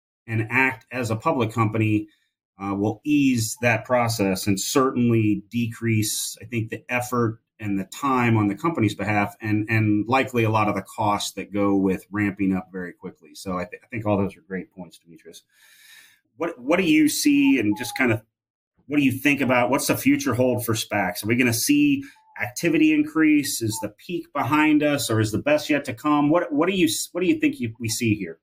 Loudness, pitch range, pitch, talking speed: -22 LUFS, 105-145 Hz, 115 Hz, 215 wpm